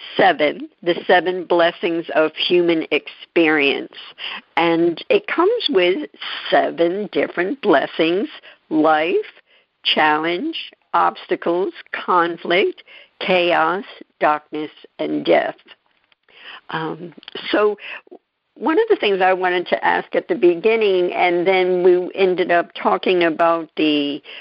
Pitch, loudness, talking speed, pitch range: 175 Hz, -18 LUFS, 105 wpm, 165-200 Hz